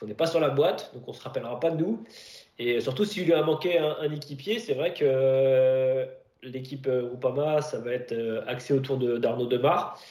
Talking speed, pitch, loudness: 240 wpm, 160 Hz, -27 LUFS